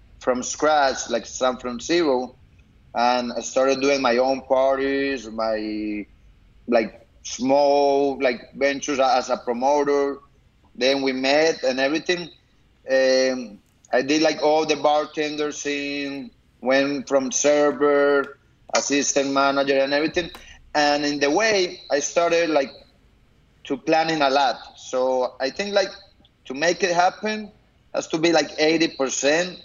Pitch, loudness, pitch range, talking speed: 140 Hz, -21 LUFS, 130-150 Hz, 130 wpm